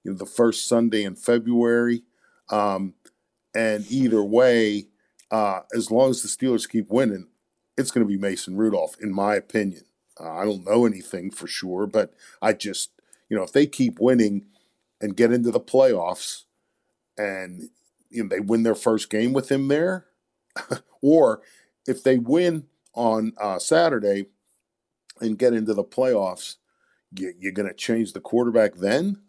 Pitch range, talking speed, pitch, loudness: 100-120 Hz, 160 wpm, 110 Hz, -23 LUFS